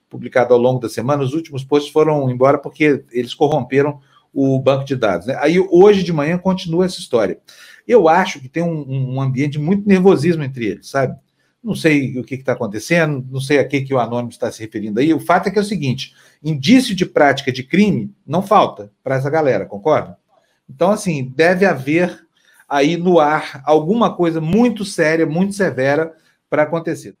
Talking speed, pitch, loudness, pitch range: 195 wpm, 150 Hz, -16 LUFS, 135-175 Hz